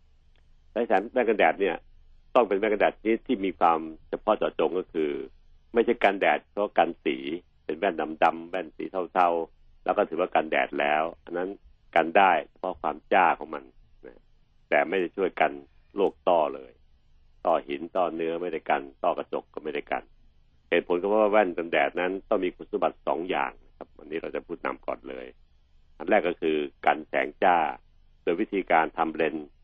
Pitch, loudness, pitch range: 75 Hz, -27 LUFS, 70-90 Hz